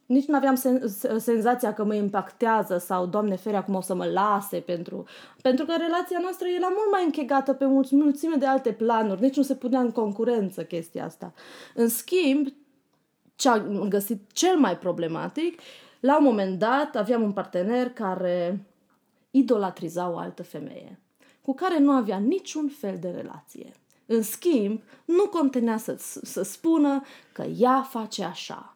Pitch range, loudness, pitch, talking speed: 205-280 Hz, -25 LUFS, 245 Hz, 155 wpm